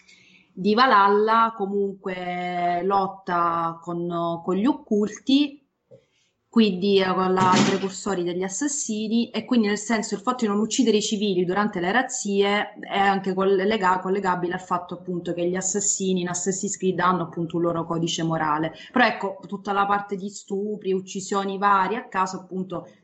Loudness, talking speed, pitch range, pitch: -23 LUFS, 155 wpm, 180-210 Hz, 195 Hz